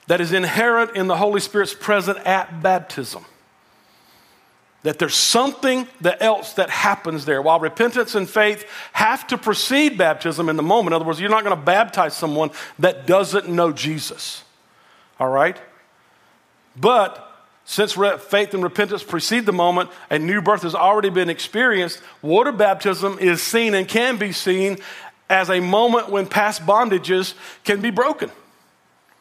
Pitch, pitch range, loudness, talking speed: 195 Hz, 175-210 Hz, -19 LUFS, 155 wpm